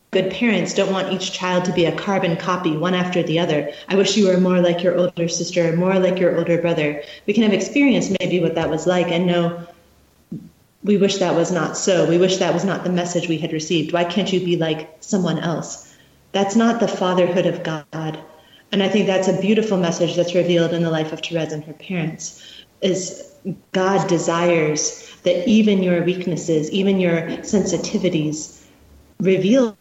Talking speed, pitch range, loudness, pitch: 195 wpm, 165-190 Hz, -19 LUFS, 175 Hz